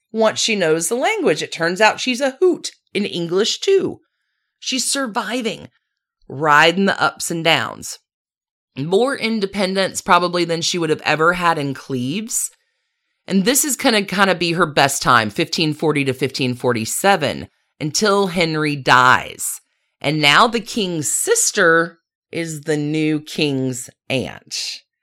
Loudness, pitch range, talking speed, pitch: -17 LUFS, 155-235 Hz, 140 wpm, 175 Hz